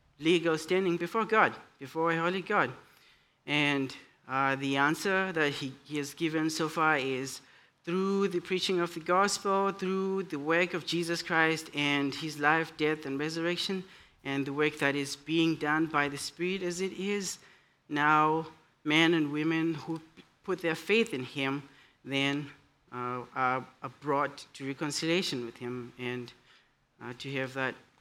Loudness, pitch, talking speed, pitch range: -30 LUFS, 155 Hz, 155 wpm, 140-170 Hz